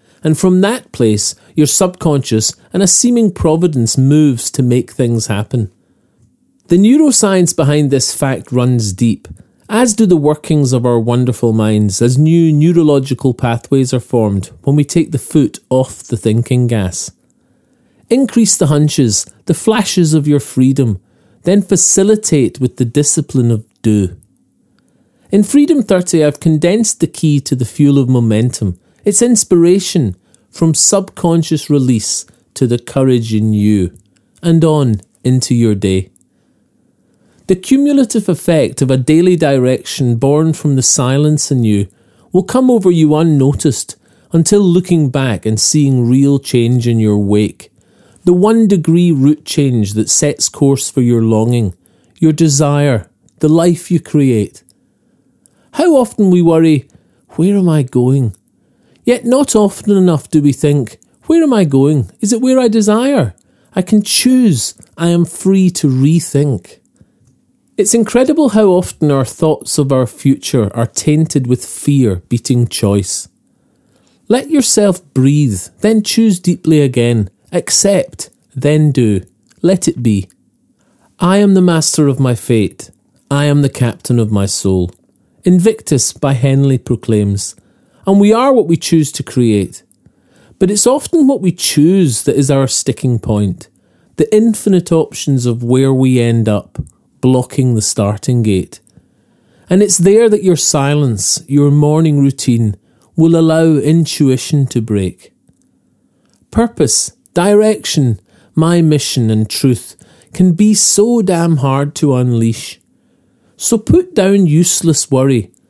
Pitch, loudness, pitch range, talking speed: 145 Hz, -12 LUFS, 120-180 Hz, 140 wpm